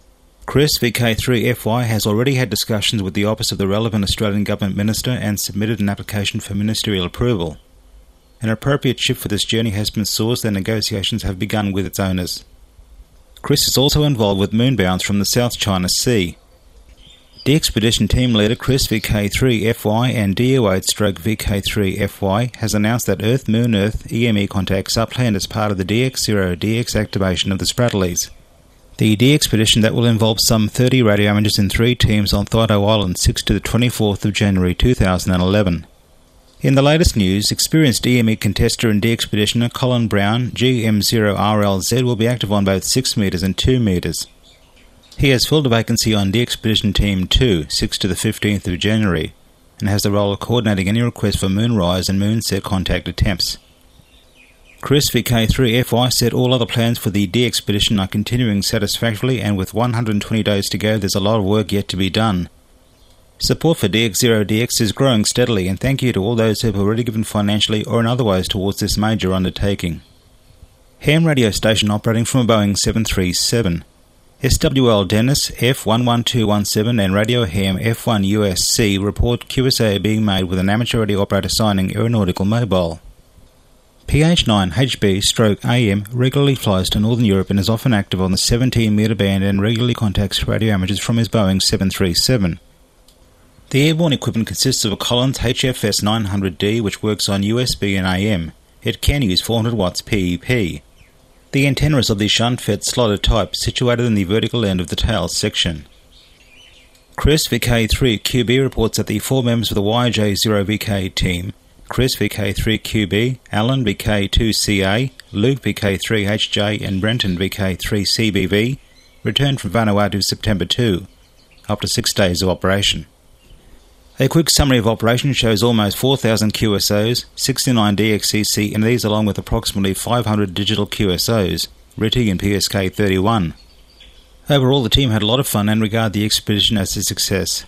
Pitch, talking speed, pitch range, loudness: 105 Hz, 160 wpm, 95-120 Hz, -17 LUFS